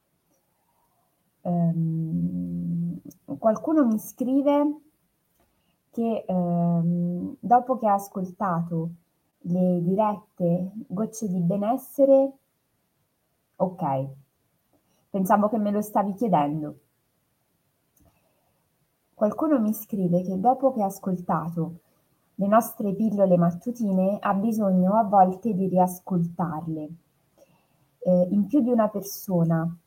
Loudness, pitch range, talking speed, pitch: -24 LUFS, 170-220 Hz, 90 wpm, 190 Hz